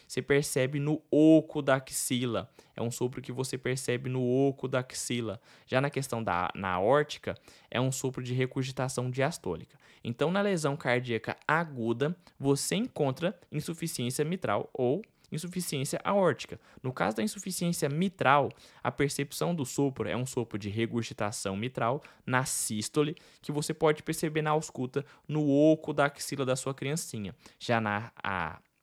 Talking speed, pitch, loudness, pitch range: 150 wpm, 135 Hz, -30 LUFS, 125-150 Hz